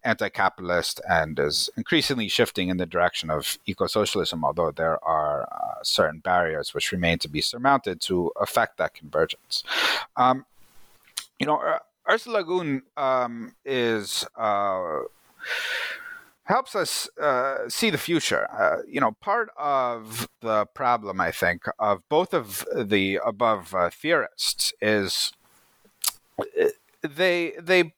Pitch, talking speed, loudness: 135 Hz, 130 wpm, -25 LUFS